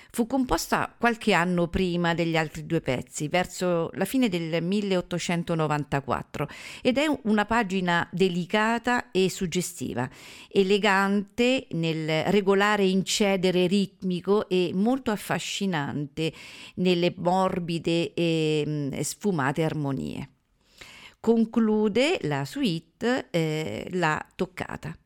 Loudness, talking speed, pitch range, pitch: -26 LUFS, 95 wpm, 165-205 Hz, 180 Hz